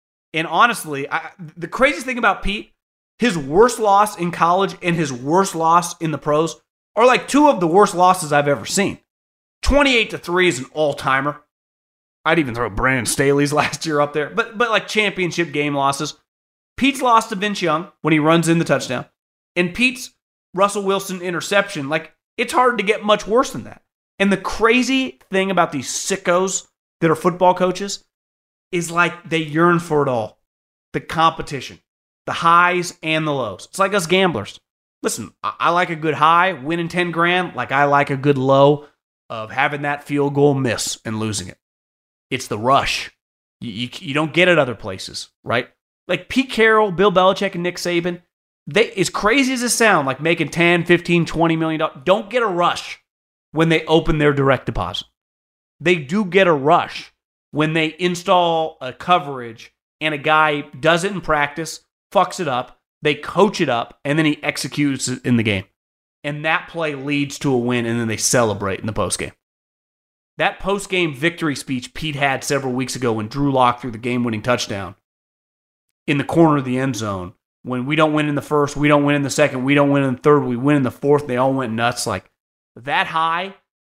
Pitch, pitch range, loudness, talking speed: 155 Hz, 135-180 Hz, -18 LUFS, 195 wpm